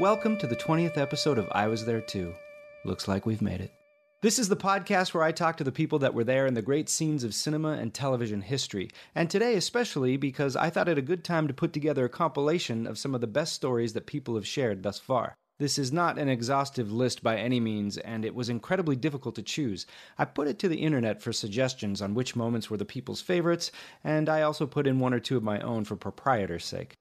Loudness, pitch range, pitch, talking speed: -29 LUFS, 115-155 Hz, 135 Hz, 240 wpm